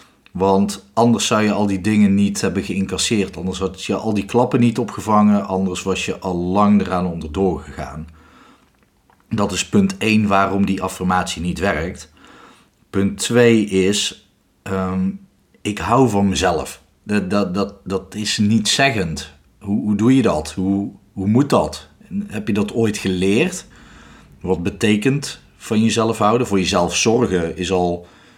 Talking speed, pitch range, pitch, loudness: 155 wpm, 95-110 Hz, 100 Hz, -18 LUFS